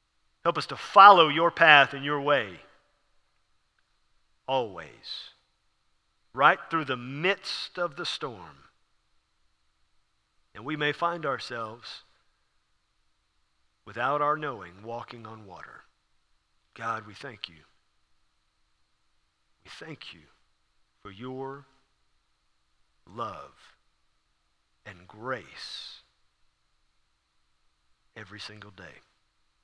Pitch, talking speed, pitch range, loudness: 120 Hz, 85 wpm, 90-150 Hz, -24 LUFS